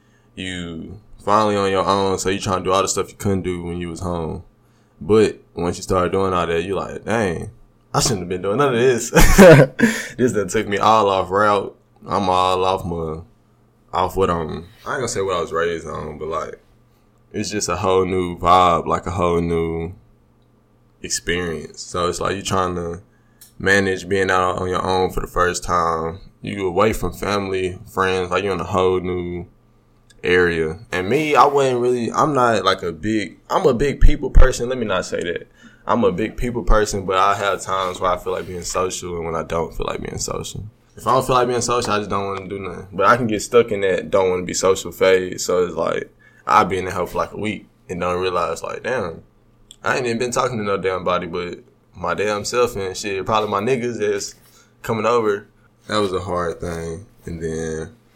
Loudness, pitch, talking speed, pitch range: -19 LUFS, 95 Hz, 225 wpm, 90-110 Hz